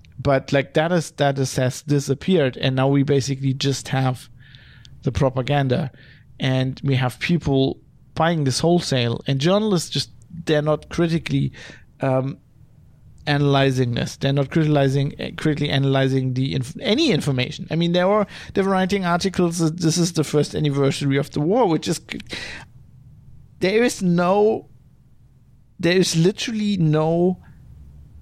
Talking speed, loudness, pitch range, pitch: 140 wpm, -21 LUFS, 130-165 Hz, 140 Hz